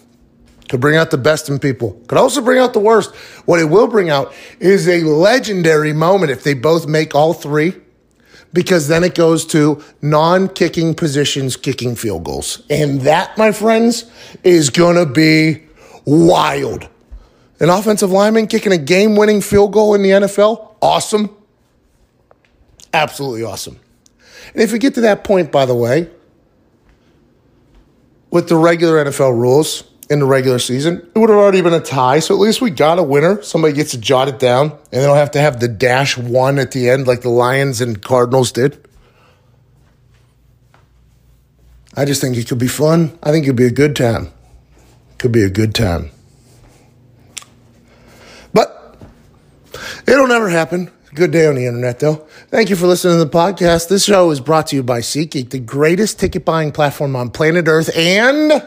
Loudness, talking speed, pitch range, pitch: -13 LUFS, 175 wpm, 130-180 Hz, 155 Hz